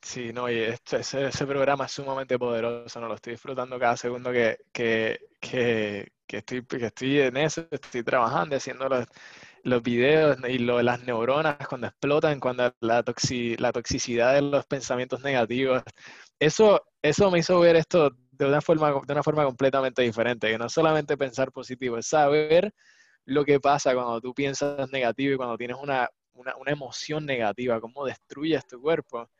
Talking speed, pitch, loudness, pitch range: 180 wpm, 130 Hz, -25 LUFS, 120-145 Hz